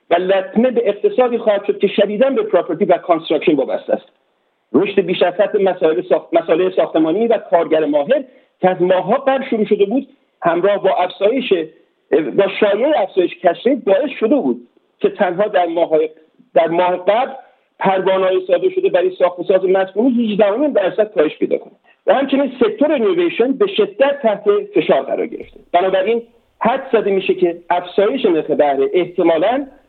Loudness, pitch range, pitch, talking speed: -16 LUFS, 180-250 Hz, 200 Hz, 155 wpm